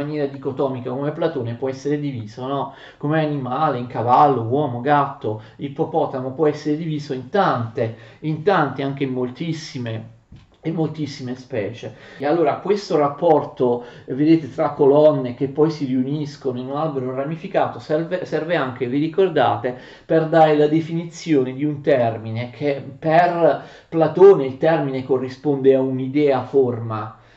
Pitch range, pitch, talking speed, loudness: 130-155 Hz, 140 Hz, 140 wpm, -20 LUFS